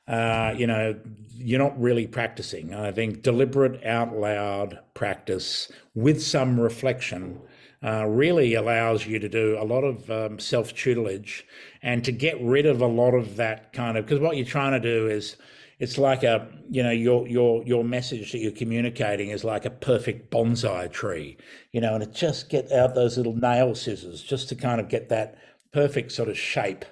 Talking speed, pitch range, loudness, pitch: 190 wpm, 110-125 Hz, -25 LUFS, 115 Hz